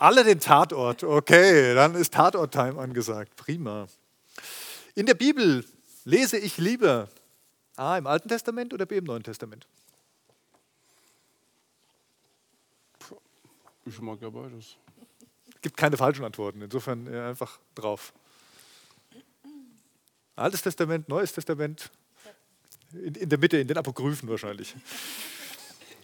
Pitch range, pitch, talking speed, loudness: 120-185 Hz, 150 Hz, 115 wpm, -24 LUFS